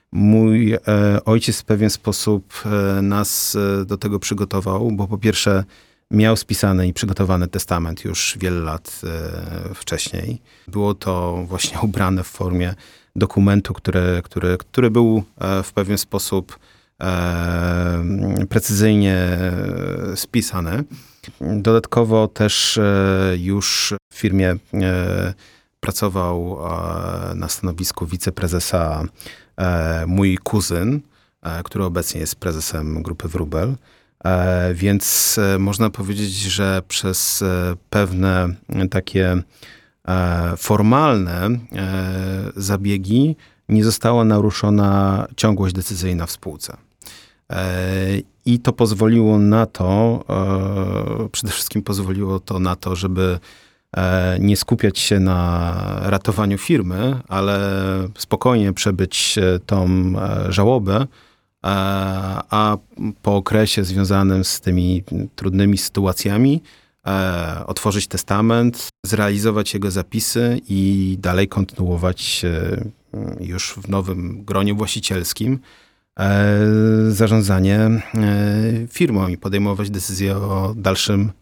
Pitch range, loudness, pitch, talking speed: 90-105 Hz, -19 LUFS, 100 Hz, 90 wpm